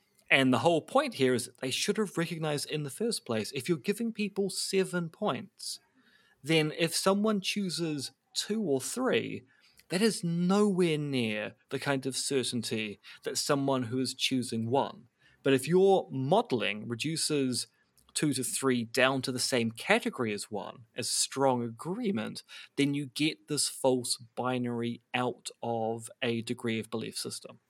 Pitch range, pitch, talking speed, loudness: 125-175 Hz, 135 Hz, 160 wpm, -30 LUFS